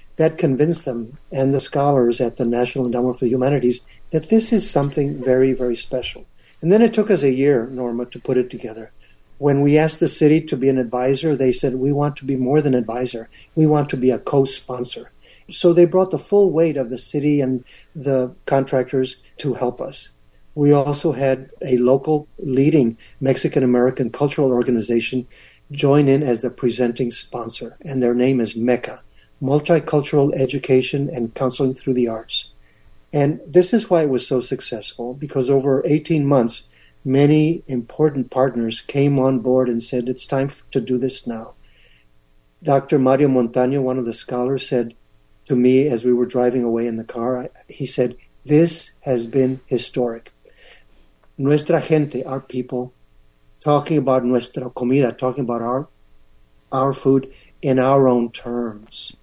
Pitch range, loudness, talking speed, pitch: 125-145 Hz, -19 LUFS, 170 wpm, 130 Hz